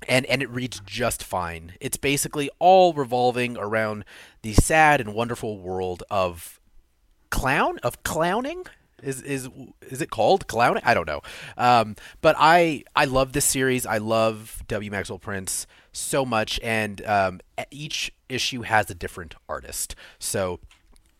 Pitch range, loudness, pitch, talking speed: 95-135 Hz, -23 LUFS, 110 Hz, 145 wpm